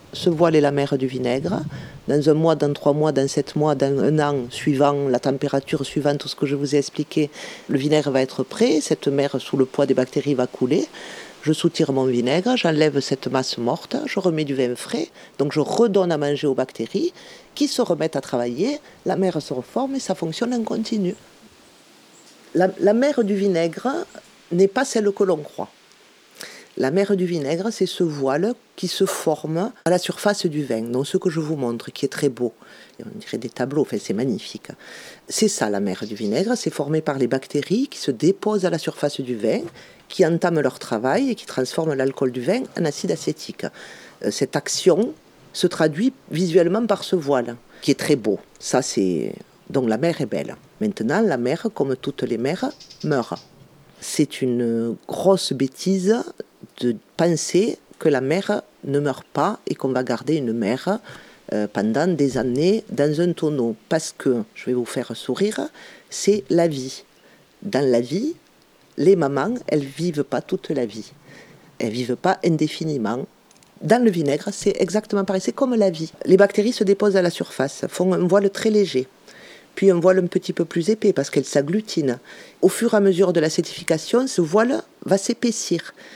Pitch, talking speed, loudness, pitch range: 165 Hz, 190 wpm, -21 LUFS, 140-195 Hz